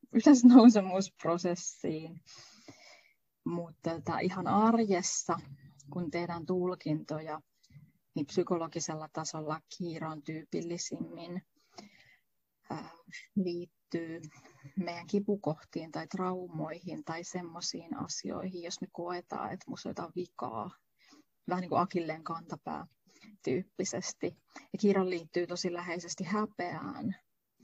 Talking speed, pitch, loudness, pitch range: 85 wpm, 175 Hz, -32 LUFS, 160-185 Hz